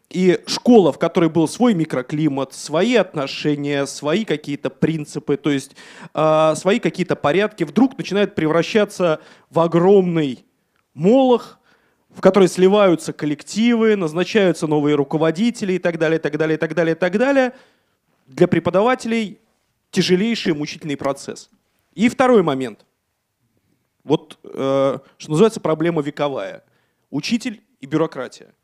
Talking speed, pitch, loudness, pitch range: 125 wpm, 170 Hz, -18 LUFS, 150-205 Hz